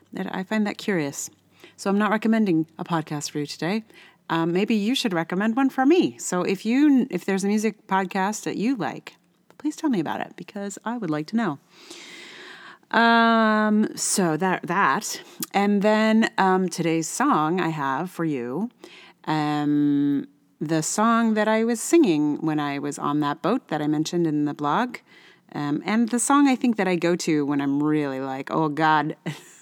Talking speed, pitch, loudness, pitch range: 185 wpm, 190 Hz, -23 LUFS, 155-225 Hz